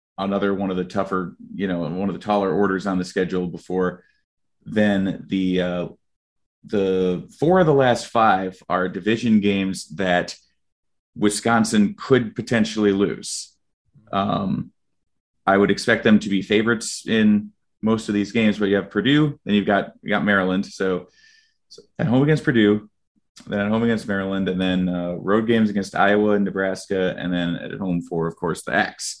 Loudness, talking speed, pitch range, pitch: -21 LUFS, 175 wpm, 95-110 Hz, 100 Hz